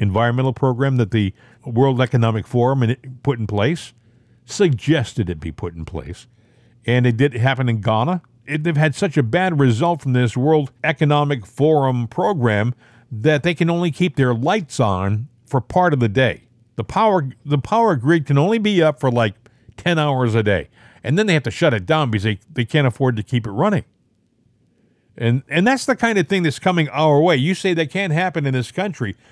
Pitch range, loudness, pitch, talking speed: 115-155 Hz, -18 LUFS, 130 Hz, 205 wpm